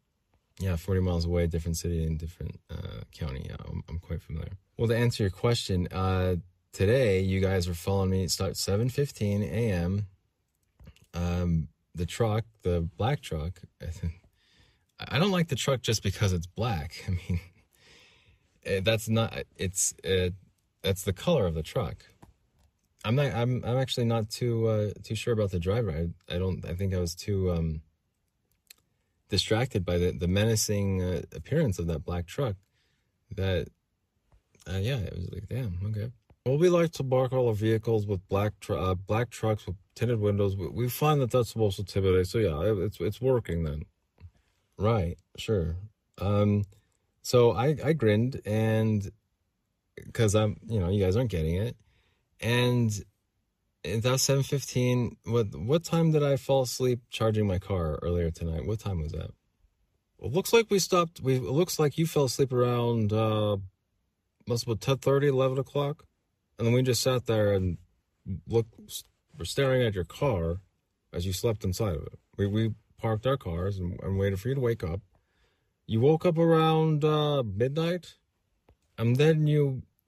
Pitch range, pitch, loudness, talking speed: 90-120 Hz, 105 Hz, -28 LUFS, 170 wpm